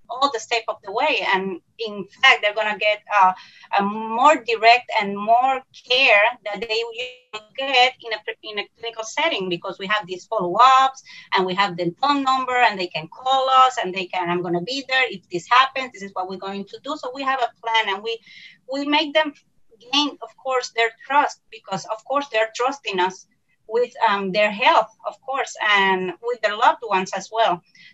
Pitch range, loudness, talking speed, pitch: 200-265 Hz, -20 LUFS, 210 wpm, 230 Hz